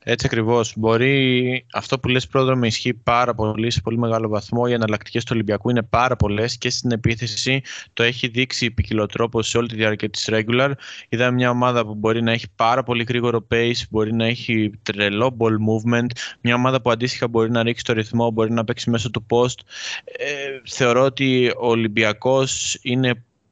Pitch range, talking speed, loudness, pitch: 110-125 Hz, 185 wpm, -20 LUFS, 120 Hz